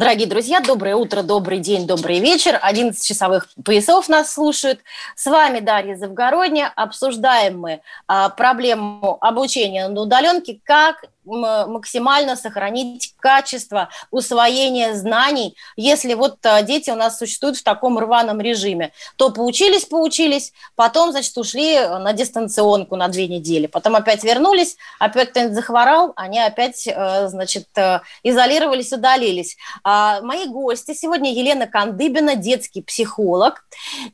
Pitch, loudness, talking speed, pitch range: 240 Hz, -17 LUFS, 120 wpm, 210-275 Hz